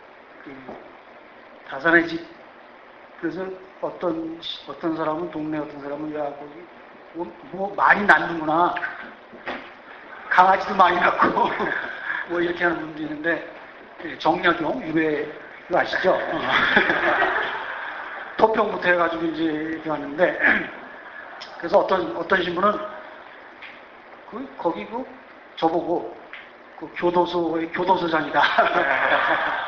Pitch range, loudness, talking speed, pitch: 155-180 Hz, -22 LUFS, 200 characters per minute, 165 Hz